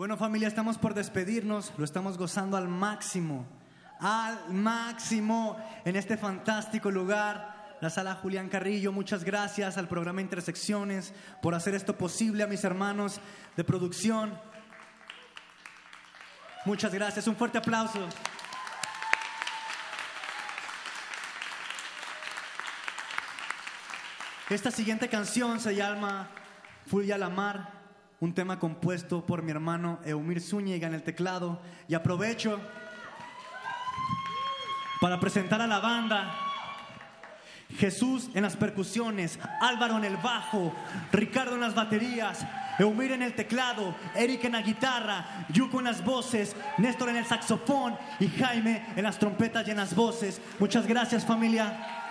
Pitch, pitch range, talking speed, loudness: 210 Hz, 190-225 Hz, 120 wpm, -31 LUFS